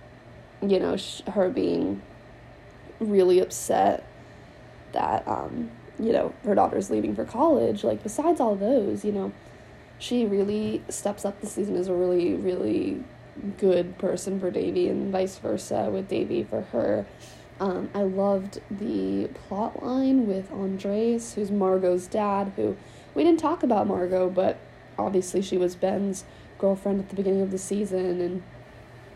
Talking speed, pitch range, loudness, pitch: 150 wpm, 180-210 Hz, -26 LUFS, 195 Hz